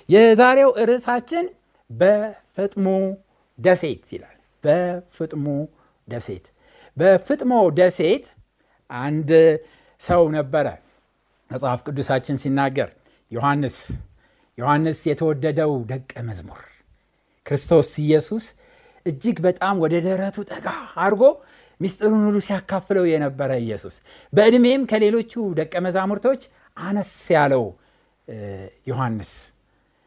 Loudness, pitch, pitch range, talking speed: -20 LUFS, 170 Hz, 140-205 Hz, 80 wpm